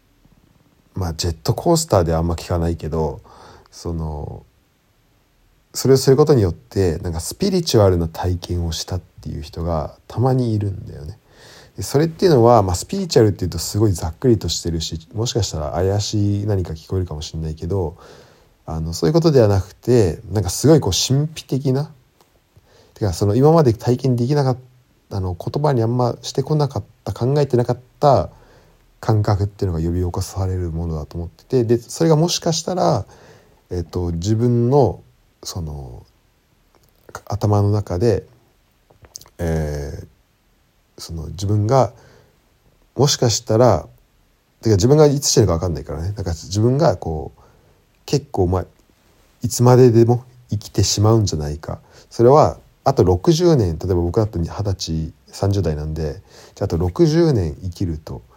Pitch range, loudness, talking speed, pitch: 85-120 Hz, -18 LUFS, 305 characters per minute, 105 Hz